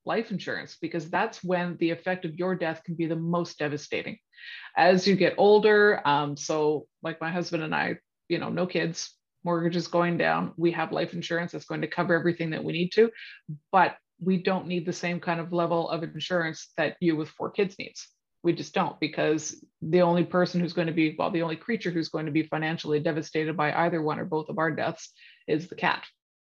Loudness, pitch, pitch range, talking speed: -27 LUFS, 170 Hz, 160-180 Hz, 215 wpm